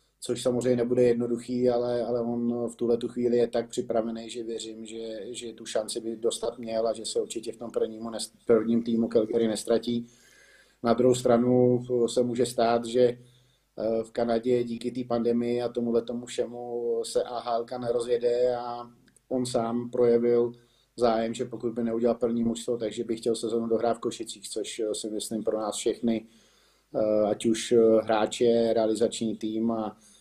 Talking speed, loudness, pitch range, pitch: 165 wpm, -27 LUFS, 115-120 Hz, 120 Hz